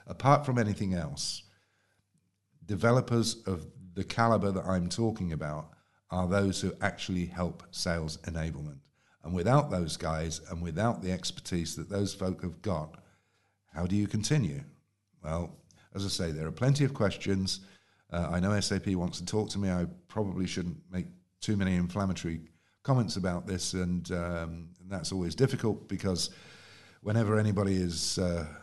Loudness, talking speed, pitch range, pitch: -32 LUFS, 155 wpm, 85-100 Hz, 95 Hz